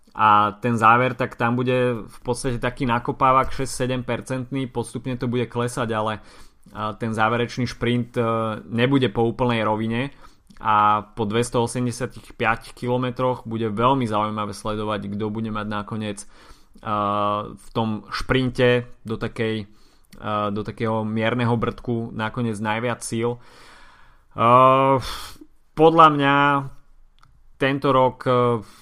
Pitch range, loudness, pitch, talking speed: 110-125 Hz, -22 LUFS, 120 Hz, 105 wpm